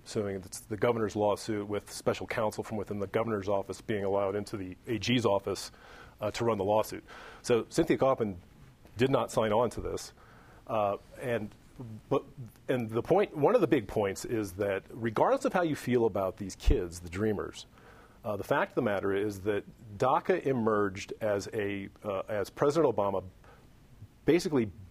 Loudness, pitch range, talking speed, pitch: -31 LUFS, 100-115 Hz, 175 wpm, 105 Hz